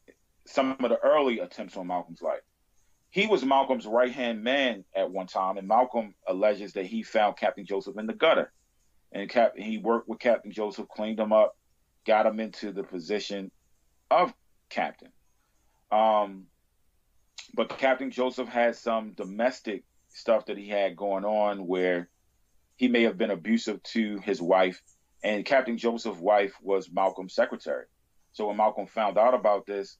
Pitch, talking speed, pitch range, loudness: 105 Hz, 160 wpm, 95-115 Hz, -27 LUFS